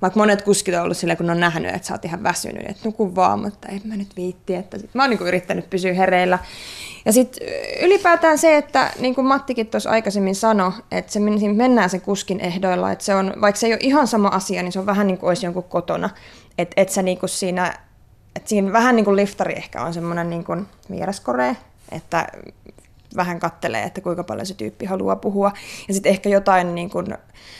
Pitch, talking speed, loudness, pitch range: 195 Hz, 215 wpm, -20 LUFS, 180-215 Hz